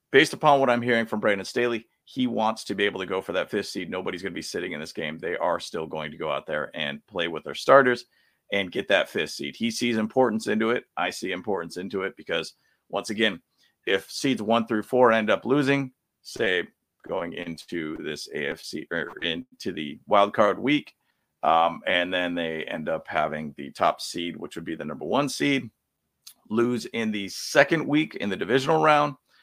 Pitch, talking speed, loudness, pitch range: 120 Hz, 210 wpm, -25 LUFS, 100-145 Hz